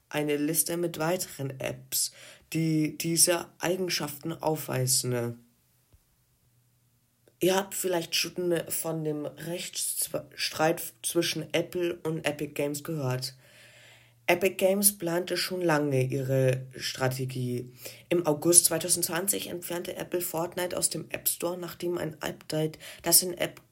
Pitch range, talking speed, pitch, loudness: 130-175 Hz, 115 wpm, 160 Hz, -28 LUFS